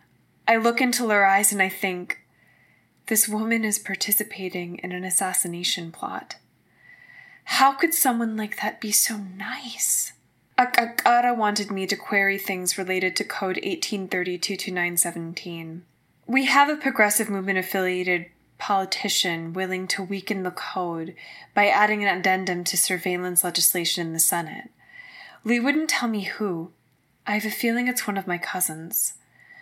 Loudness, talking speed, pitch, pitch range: -23 LUFS, 140 wpm, 195 Hz, 180-225 Hz